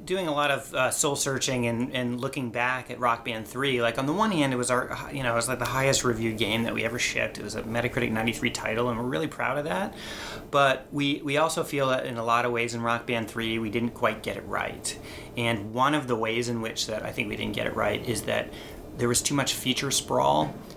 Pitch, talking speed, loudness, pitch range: 125 Hz, 265 wpm, -27 LUFS, 115-135 Hz